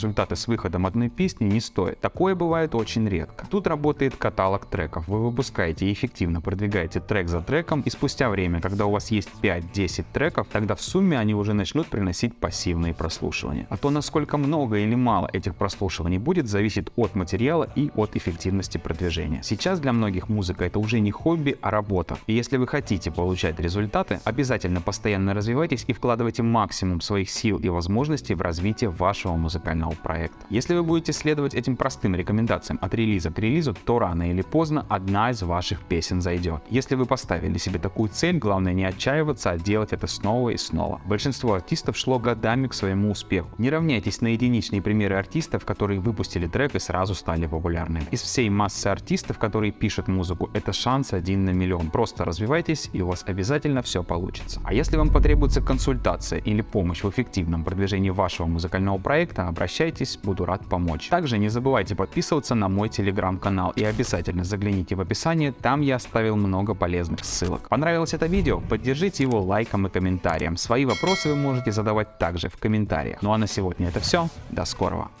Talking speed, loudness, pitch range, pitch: 175 wpm, -25 LUFS, 95-125 Hz, 105 Hz